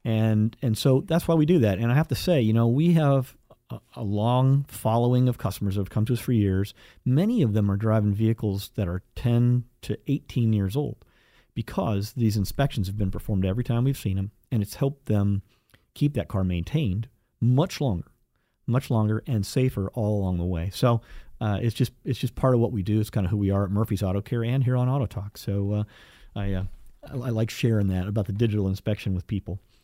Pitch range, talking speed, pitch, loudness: 100-125 Hz, 225 wpm, 110 Hz, -25 LUFS